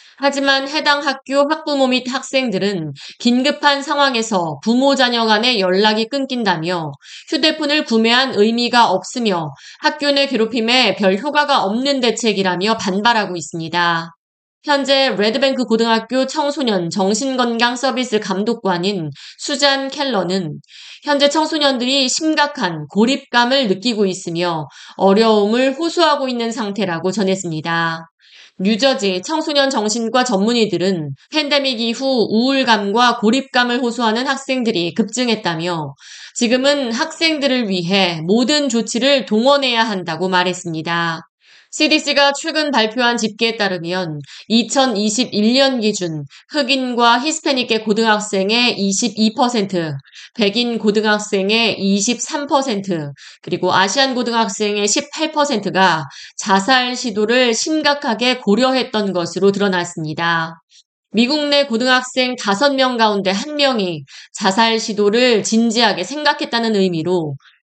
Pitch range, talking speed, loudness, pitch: 195-270 Hz, 275 characters per minute, -16 LUFS, 230 Hz